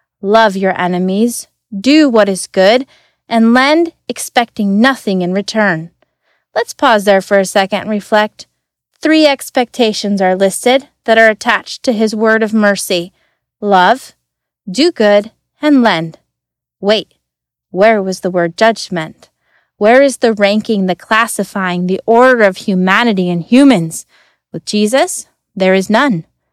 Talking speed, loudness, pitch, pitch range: 140 wpm, -12 LUFS, 210 Hz, 190-235 Hz